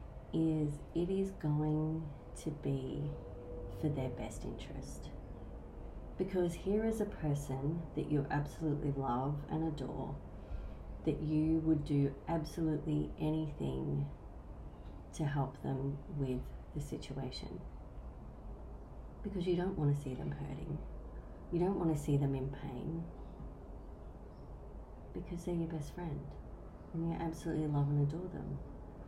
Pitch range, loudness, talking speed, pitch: 130-160 Hz, -38 LUFS, 125 wpm, 150 Hz